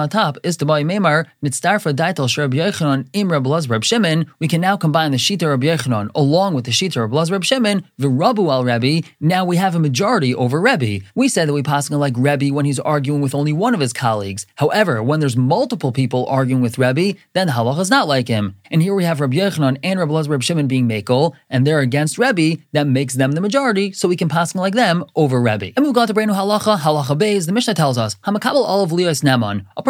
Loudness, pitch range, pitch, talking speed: -17 LUFS, 135-185 Hz, 150 Hz, 225 wpm